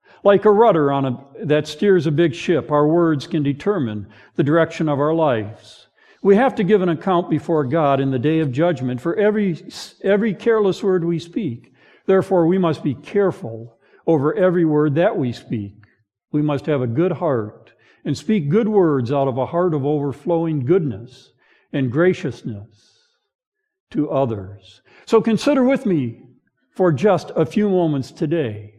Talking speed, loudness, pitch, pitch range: 170 wpm, -19 LUFS, 160 Hz, 135-190 Hz